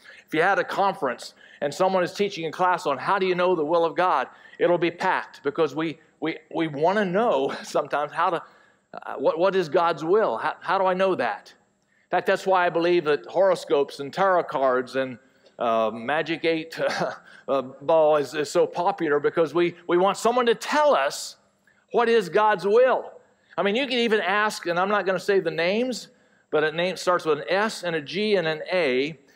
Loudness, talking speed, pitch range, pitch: -23 LUFS, 215 wpm, 160-200 Hz, 175 Hz